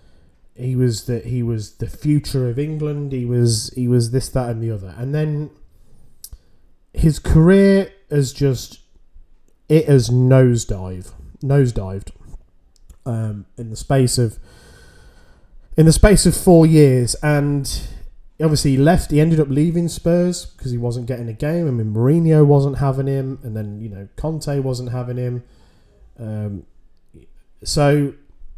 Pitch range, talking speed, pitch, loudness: 110-150 Hz, 150 wpm, 125 Hz, -17 LUFS